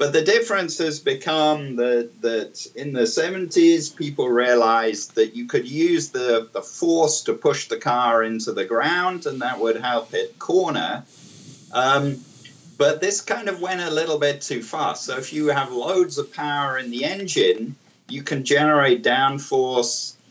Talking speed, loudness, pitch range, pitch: 170 wpm, -21 LUFS, 125-175 Hz, 150 Hz